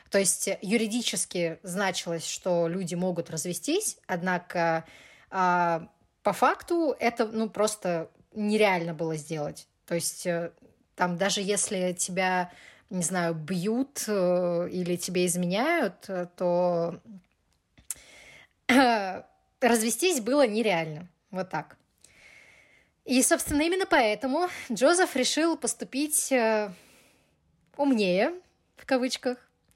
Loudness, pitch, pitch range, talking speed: -27 LUFS, 195 Hz, 175-240 Hz, 100 wpm